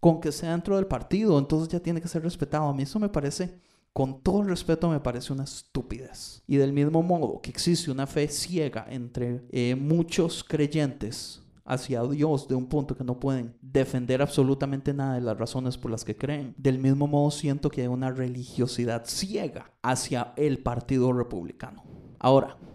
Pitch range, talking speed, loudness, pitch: 125-155 Hz, 185 wpm, -27 LUFS, 140 Hz